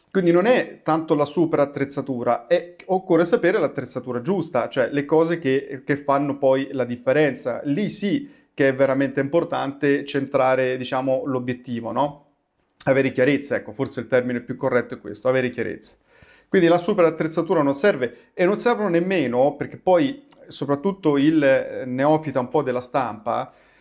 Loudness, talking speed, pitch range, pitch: -22 LUFS, 155 wpm, 130-170 Hz, 140 Hz